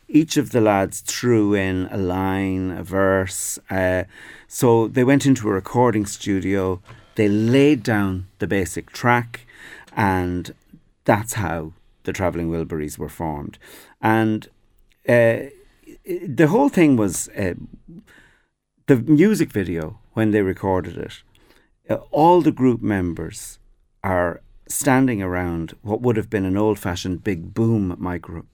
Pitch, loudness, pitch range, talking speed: 105 Hz, -20 LUFS, 95-115 Hz, 135 wpm